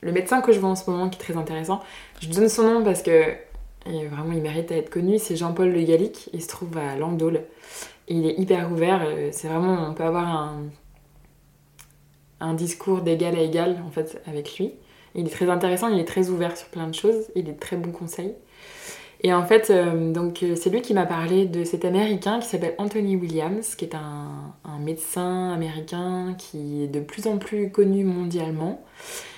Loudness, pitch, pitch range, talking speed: -24 LUFS, 175 Hz, 160-195 Hz, 200 wpm